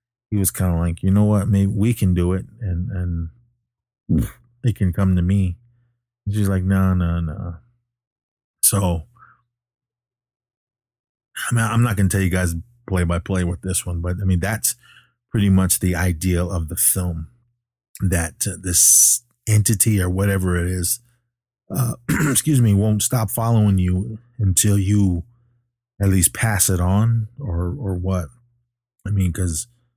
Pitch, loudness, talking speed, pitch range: 100 Hz, -19 LUFS, 160 wpm, 90-120 Hz